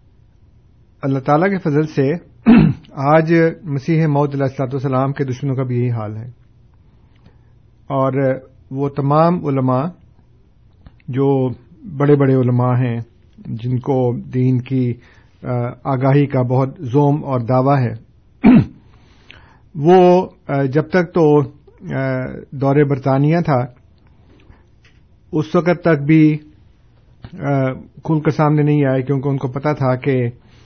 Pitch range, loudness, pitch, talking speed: 120-145 Hz, -16 LUFS, 130 Hz, 115 wpm